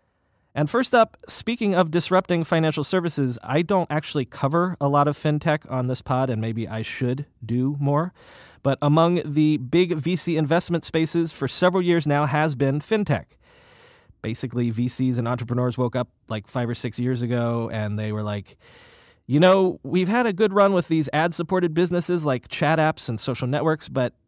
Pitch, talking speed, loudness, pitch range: 145 Hz, 185 wpm, -23 LUFS, 125-170 Hz